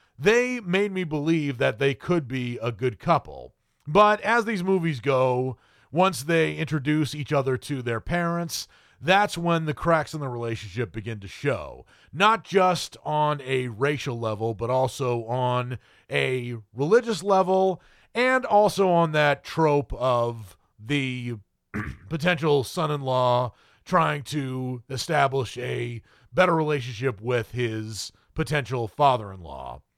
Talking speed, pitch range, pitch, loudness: 140 wpm, 125-170 Hz, 140 Hz, -25 LUFS